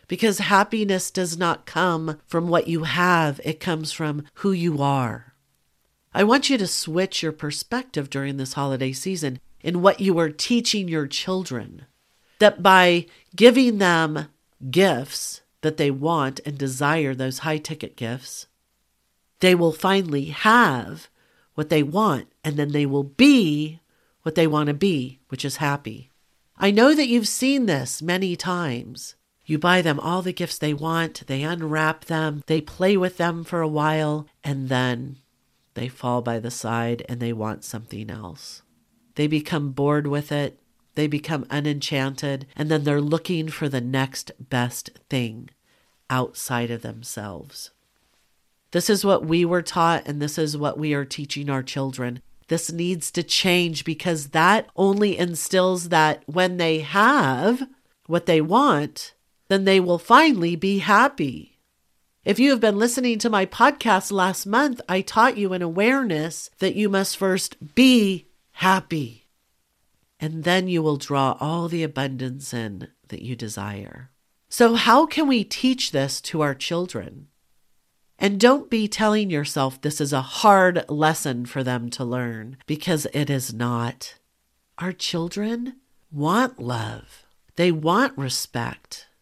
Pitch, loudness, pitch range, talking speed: 155 Hz, -22 LUFS, 135-185 Hz, 155 wpm